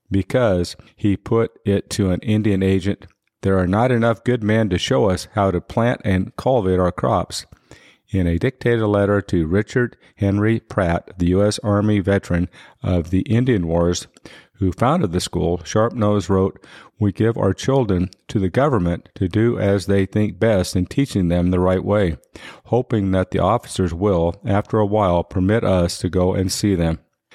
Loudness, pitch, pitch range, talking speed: -19 LUFS, 100 Hz, 90-110 Hz, 180 wpm